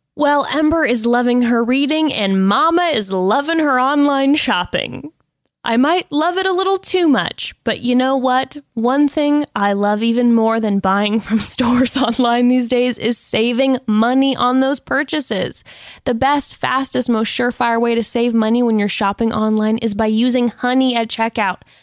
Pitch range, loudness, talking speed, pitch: 225-275 Hz, -16 LUFS, 175 wpm, 245 Hz